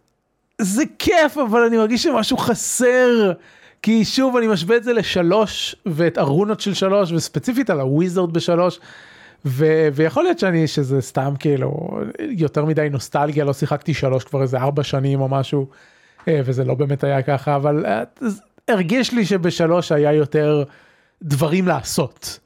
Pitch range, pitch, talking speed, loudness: 145-220 Hz, 170 Hz, 145 wpm, -18 LUFS